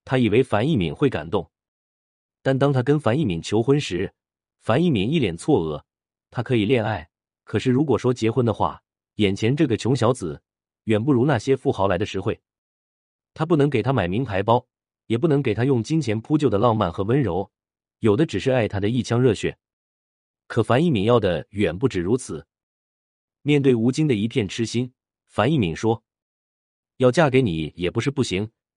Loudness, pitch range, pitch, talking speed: -22 LUFS, 90-130 Hz, 110 Hz, 265 characters per minute